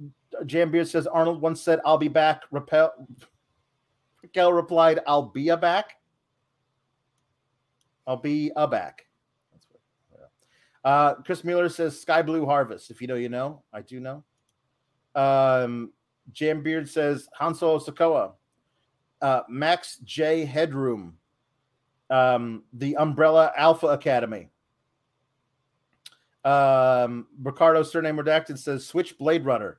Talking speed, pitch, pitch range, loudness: 115 wpm, 145 Hz, 130-160 Hz, -23 LUFS